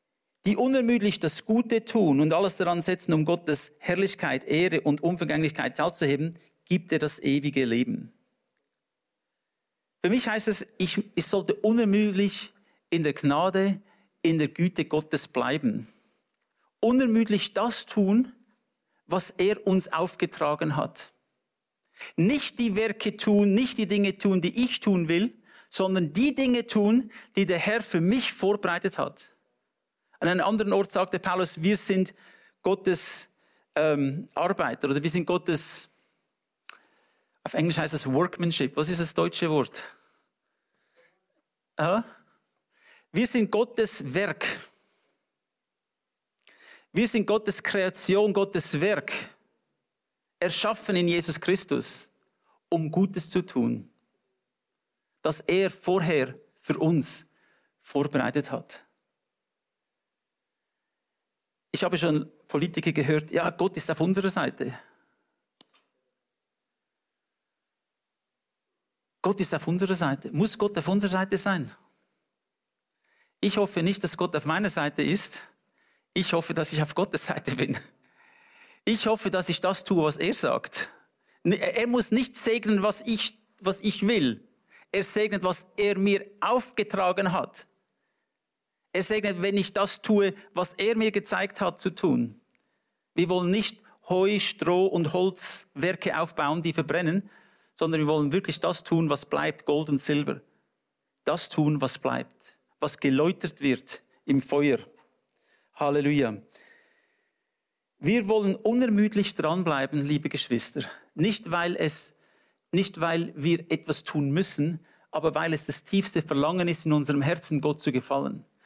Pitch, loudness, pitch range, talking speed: 185 Hz, -26 LUFS, 160-205 Hz, 130 wpm